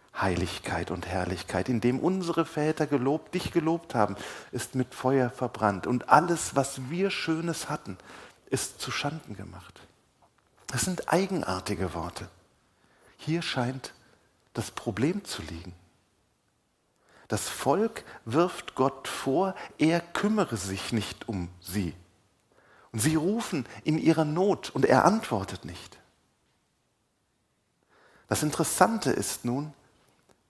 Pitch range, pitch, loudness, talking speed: 95-160 Hz, 125 Hz, -28 LUFS, 120 wpm